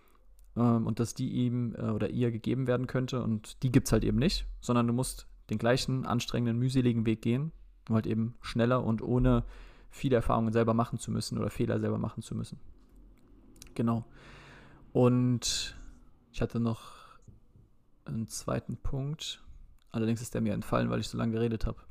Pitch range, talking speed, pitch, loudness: 110-125 Hz, 170 wpm, 115 Hz, -31 LUFS